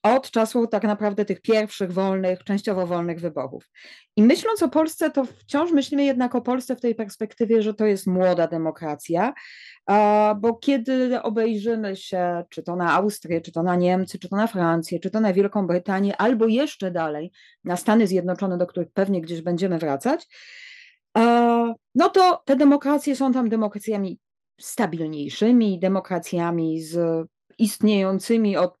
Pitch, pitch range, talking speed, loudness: 210 Hz, 180-235 Hz, 150 wpm, -22 LUFS